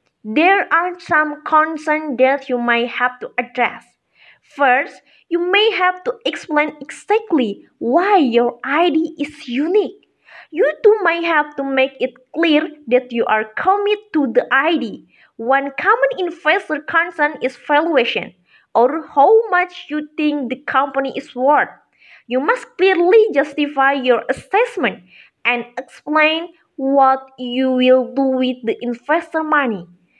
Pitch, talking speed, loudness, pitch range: 295 Hz, 135 wpm, -17 LUFS, 255-340 Hz